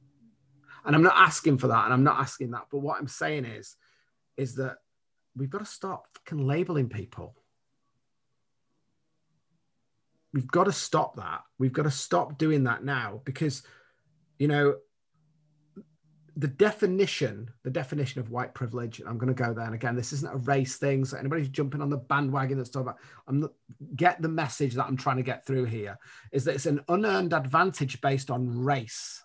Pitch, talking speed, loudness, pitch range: 140 Hz, 180 wpm, -28 LUFS, 130-155 Hz